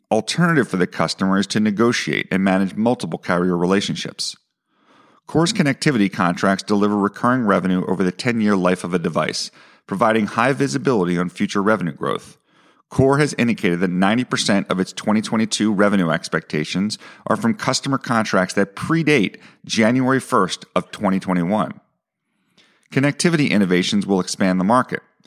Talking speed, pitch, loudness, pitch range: 140 wpm, 105 Hz, -19 LUFS, 95-120 Hz